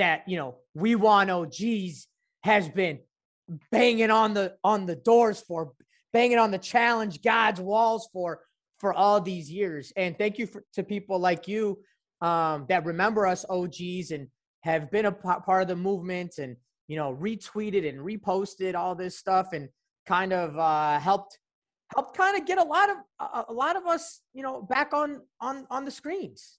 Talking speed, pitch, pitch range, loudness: 185 wpm, 195 Hz, 180-230 Hz, -26 LUFS